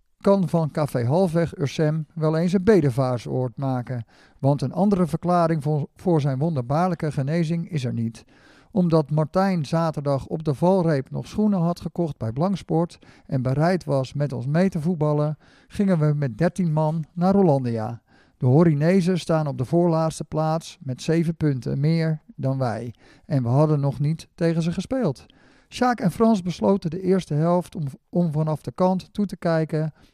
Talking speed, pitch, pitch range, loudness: 170 wpm, 160 Hz, 140-175 Hz, -23 LUFS